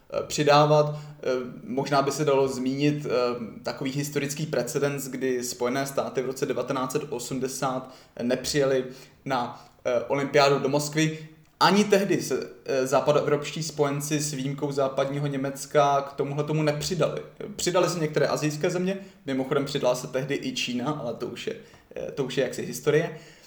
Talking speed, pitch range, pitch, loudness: 135 wpm, 135-150 Hz, 140 Hz, -26 LUFS